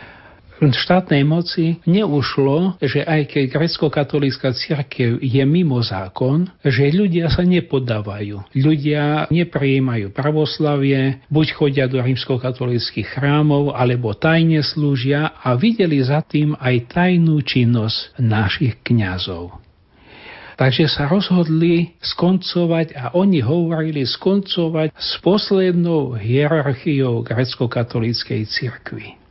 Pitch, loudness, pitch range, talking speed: 145 Hz, -18 LUFS, 125-165 Hz, 100 wpm